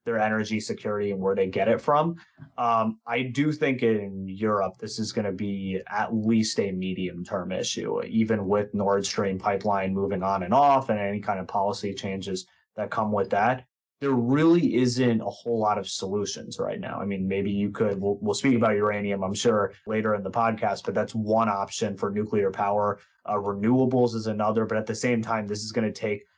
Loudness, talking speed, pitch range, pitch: -26 LUFS, 210 wpm, 100-115 Hz, 105 Hz